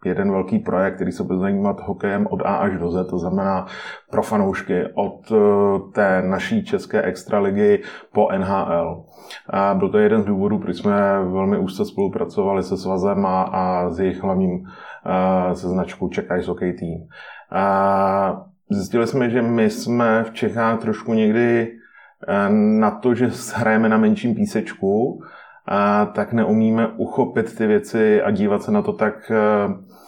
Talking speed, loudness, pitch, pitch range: 155 wpm, -20 LUFS, 110 Hz, 95-125 Hz